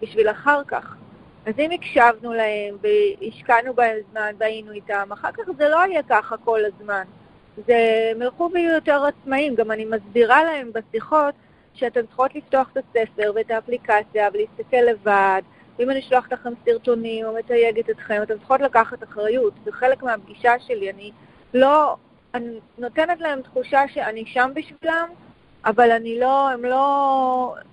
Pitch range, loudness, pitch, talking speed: 220-275 Hz, -20 LUFS, 240 Hz, 150 wpm